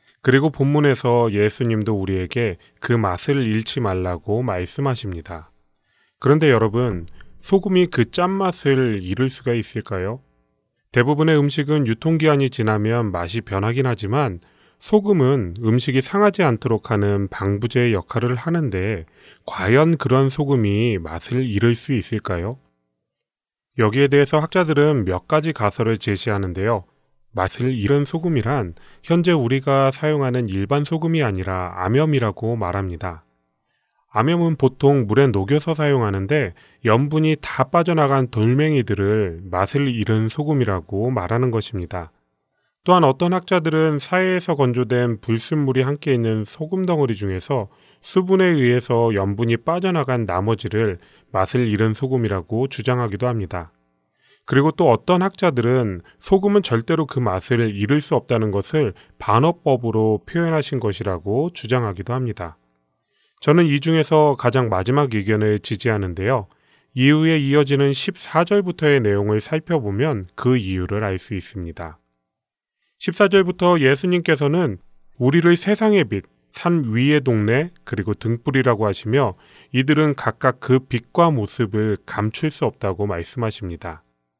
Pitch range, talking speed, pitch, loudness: 100-150 Hz, 305 characters per minute, 120 Hz, -19 LUFS